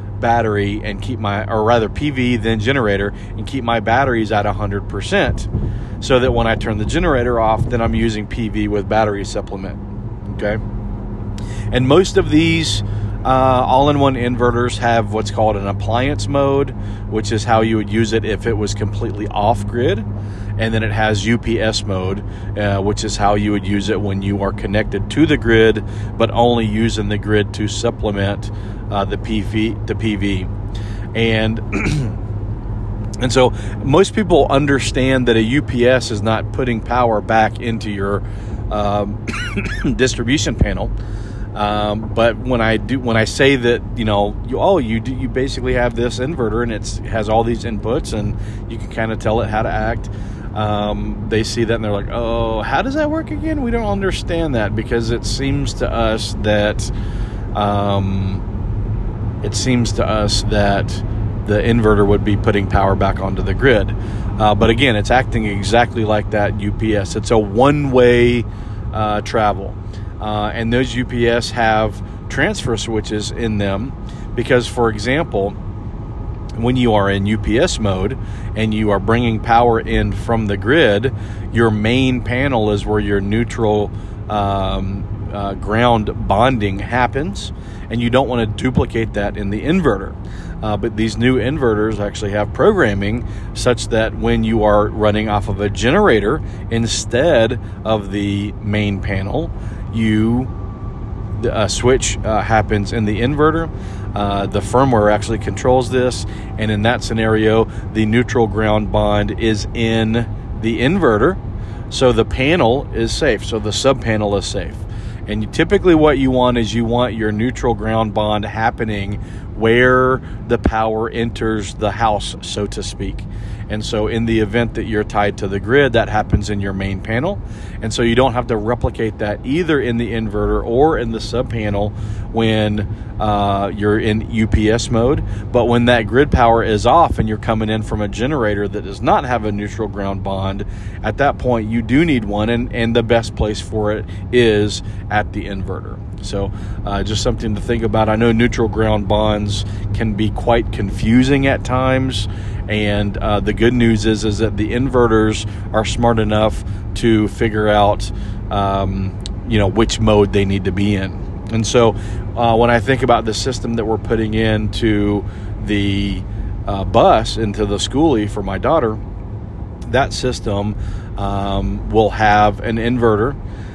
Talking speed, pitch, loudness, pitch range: 165 wpm, 105 Hz, -17 LUFS, 105-115 Hz